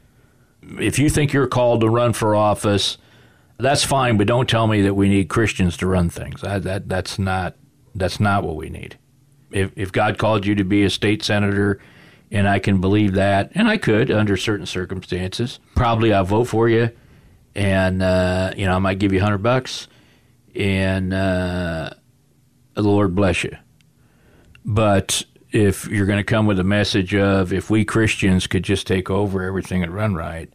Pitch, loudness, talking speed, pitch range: 100 Hz, -19 LUFS, 185 wpm, 95-115 Hz